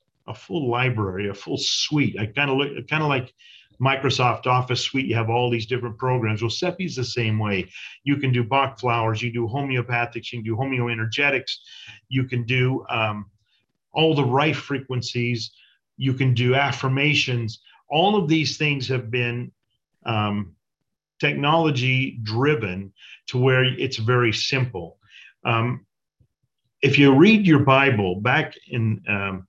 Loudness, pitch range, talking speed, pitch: -22 LUFS, 115-135 Hz, 155 wpm, 125 Hz